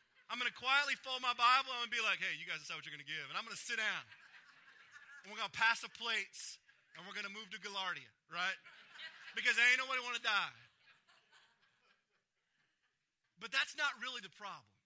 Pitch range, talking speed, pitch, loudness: 210-270 Hz, 220 wpm, 240 Hz, -37 LUFS